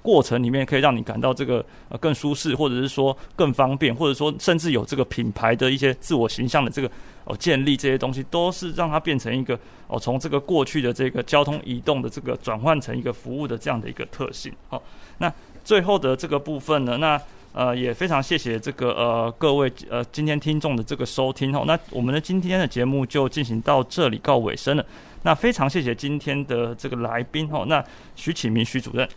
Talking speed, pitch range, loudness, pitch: 330 characters per minute, 120-150 Hz, -23 LUFS, 135 Hz